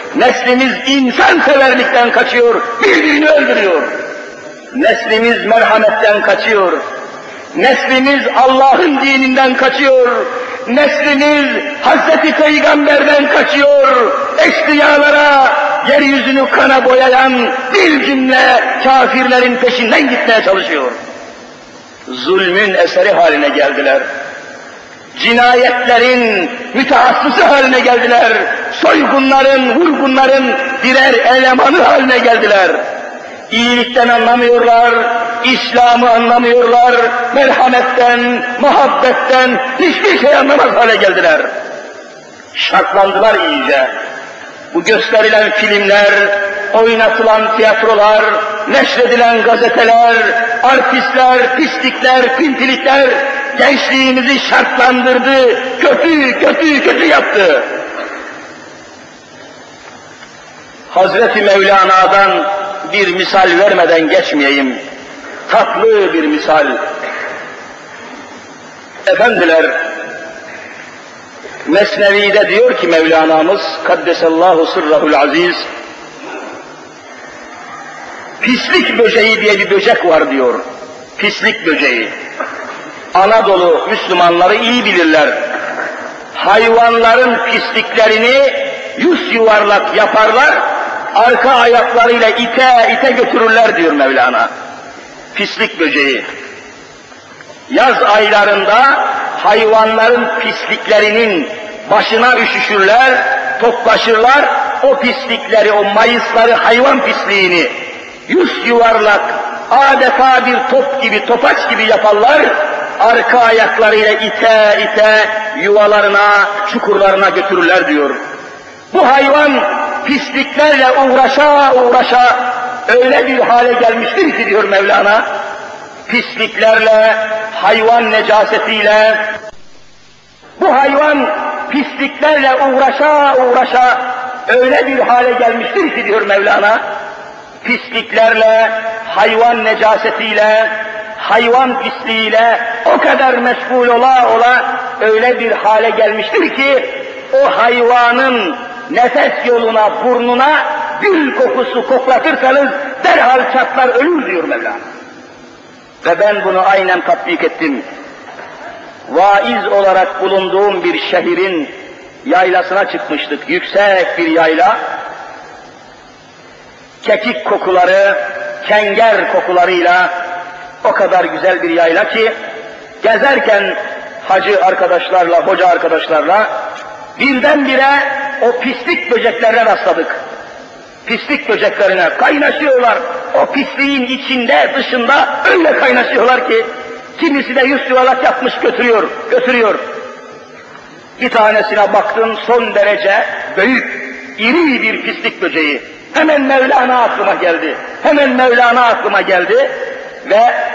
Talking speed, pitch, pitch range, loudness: 80 wpm, 240 Hz, 215-270 Hz, -9 LUFS